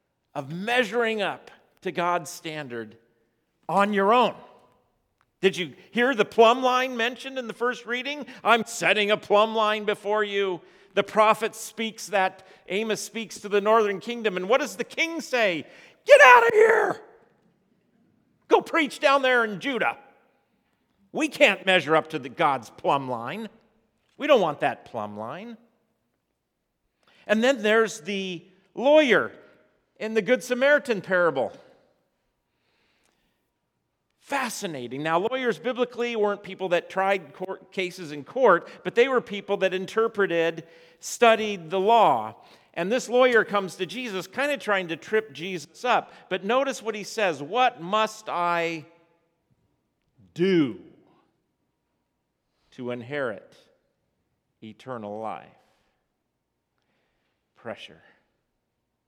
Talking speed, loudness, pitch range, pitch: 130 wpm, -23 LUFS, 170-235 Hz, 205 Hz